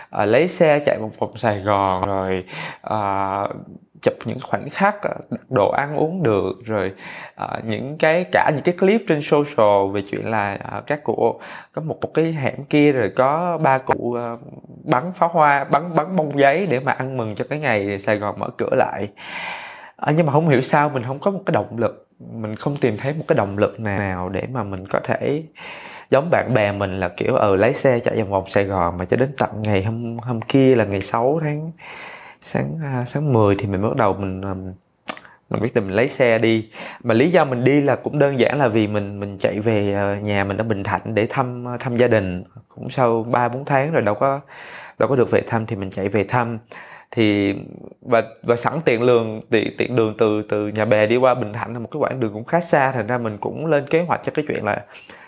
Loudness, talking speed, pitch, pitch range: -20 LUFS, 230 wpm, 115 Hz, 105-140 Hz